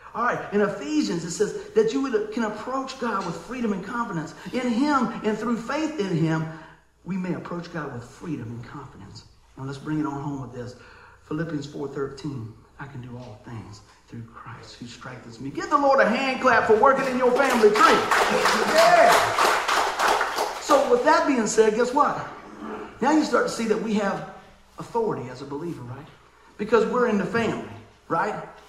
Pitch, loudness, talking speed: 195 Hz, -23 LUFS, 190 wpm